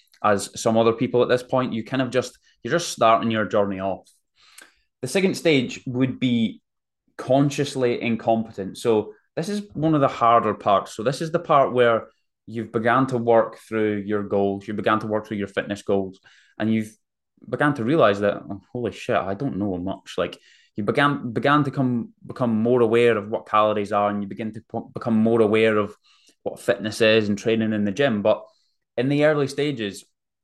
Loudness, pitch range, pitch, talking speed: -22 LUFS, 105-125 Hz, 115 Hz, 200 wpm